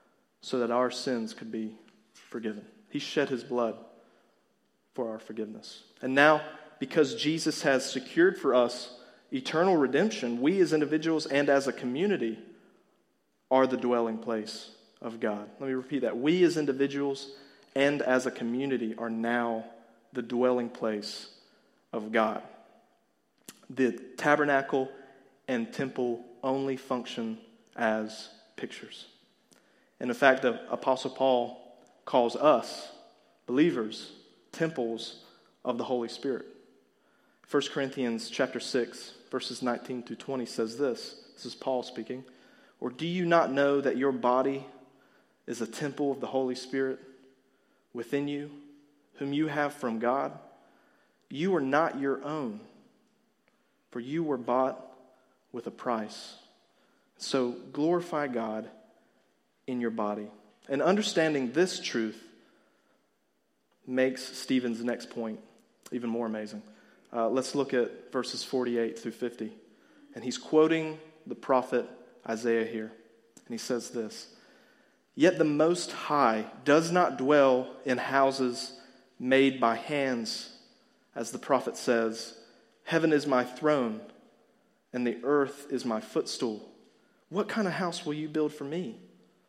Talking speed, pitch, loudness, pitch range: 130 wpm, 130 Hz, -30 LUFS, 120-145 Hz